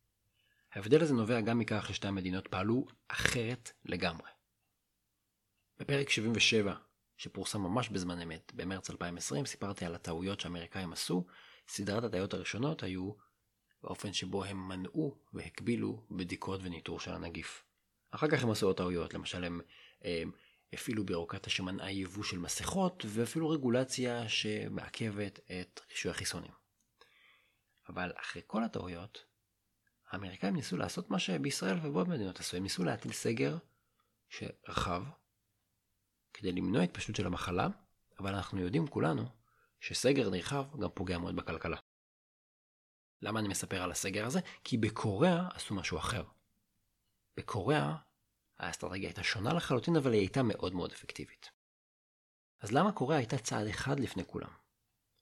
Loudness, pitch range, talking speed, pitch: -36 LUFS, 90-115 Hz, 130 wpm, 100 Hz